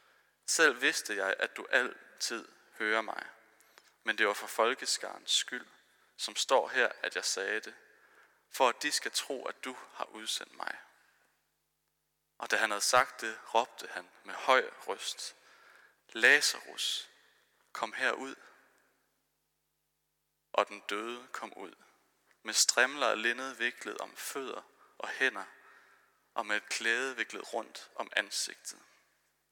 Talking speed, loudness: 135 wpm, -32 LUFS